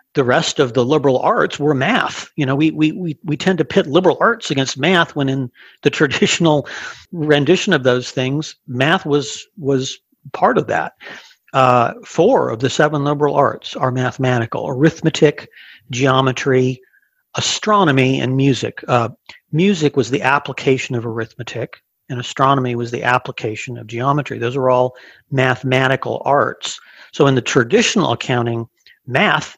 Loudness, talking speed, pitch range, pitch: -17 LUFS, 150 wpm, 125-155 Hz, 135 Hz